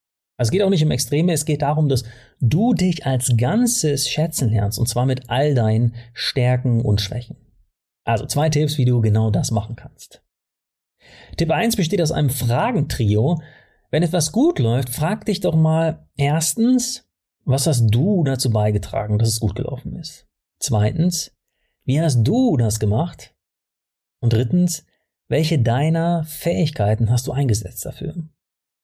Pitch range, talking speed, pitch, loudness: 115-165 Hz, 155 wpm, 135 Hz, -19 LUFS